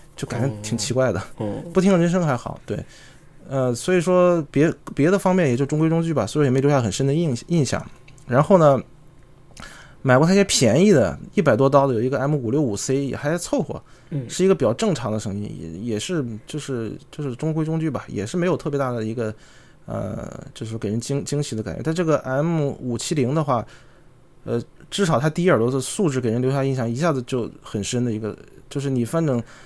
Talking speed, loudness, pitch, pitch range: 310 characters per minute, -21 LUFS, 135 Hz, 120-160 Hz